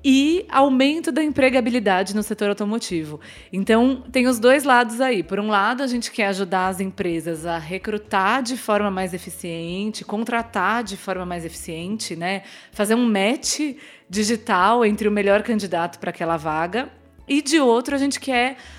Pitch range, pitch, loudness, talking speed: 190-255 Hz, 215 Hz, -21 LUFS, 165 wpm